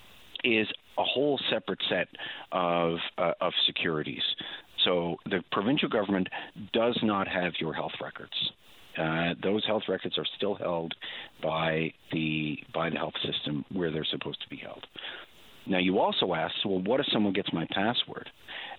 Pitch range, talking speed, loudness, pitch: 80-90 Hz, 160 wpm, -29 LUFS, 85 Hz